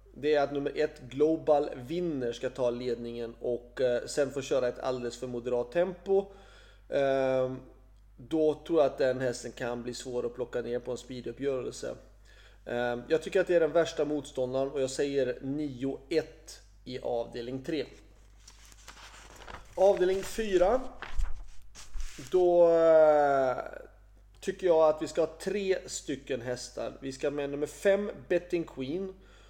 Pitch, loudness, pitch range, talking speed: 135 Hz, -30 LUFS, 120-160 Hz, 140 wpm